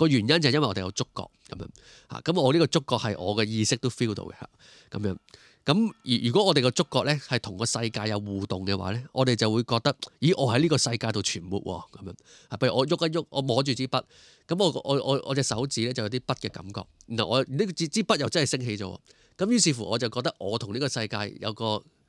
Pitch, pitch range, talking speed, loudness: 125 Hz, 110-145 Hz, 360 characters per minute, -26 LUFS